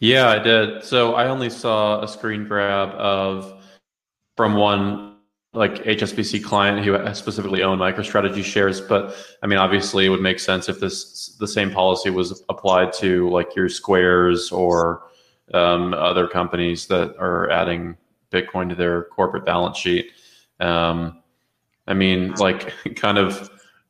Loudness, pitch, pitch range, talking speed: -20 LUFS, 95 Hz, 90-105 Hz, 150 wpm